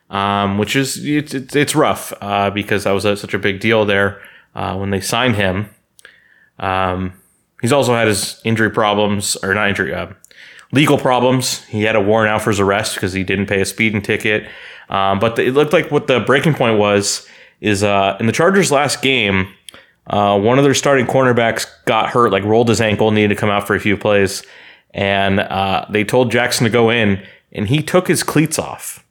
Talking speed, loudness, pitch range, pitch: 210 wpm, -15 LUFS, 100-125 Hz, 105 Hz